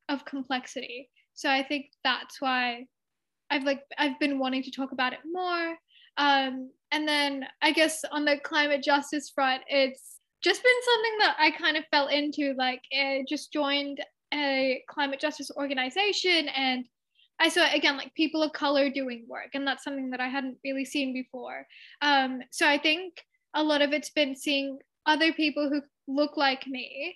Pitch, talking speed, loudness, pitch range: 285 Hz, 175 wpm, -27 LUFS, 270-300 Hz